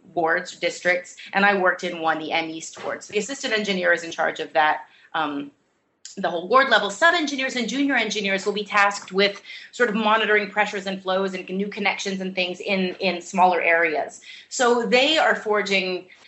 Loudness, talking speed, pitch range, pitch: -22 LUFS, 195 wpm, 175-210 Hz, 195 Hz